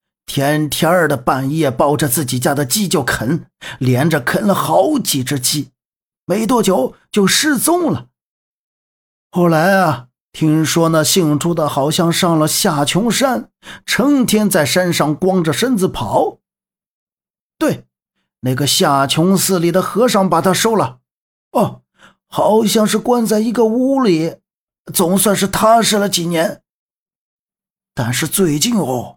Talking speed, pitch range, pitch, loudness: 190 characters per minute, 150-210 Hz, 180 Hz, -15 LUFS